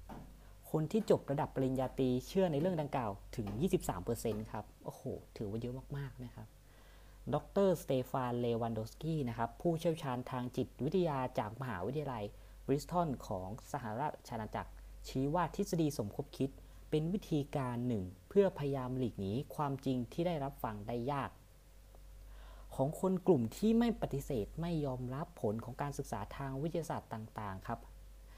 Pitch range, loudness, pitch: 110-150 Hz, -38 LUFS, 130 Hz